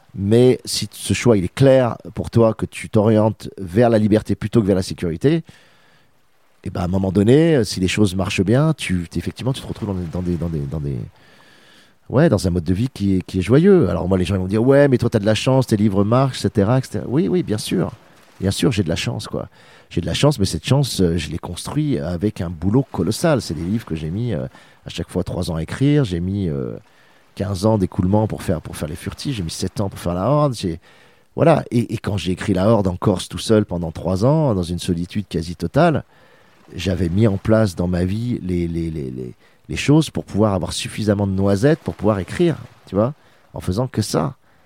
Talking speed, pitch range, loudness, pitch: 250 wpm, 90-120 Hz, -19 LUFS, 100 Hz